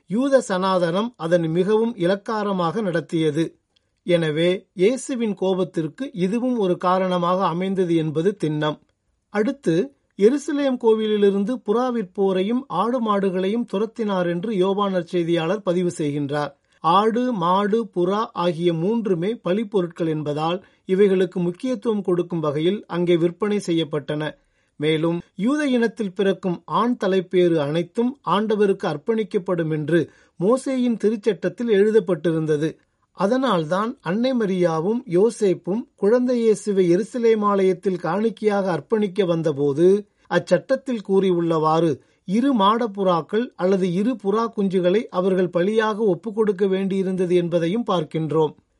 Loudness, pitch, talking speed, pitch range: -21 LUFS, 190 Hz, 95 wpm, 175-220 Hz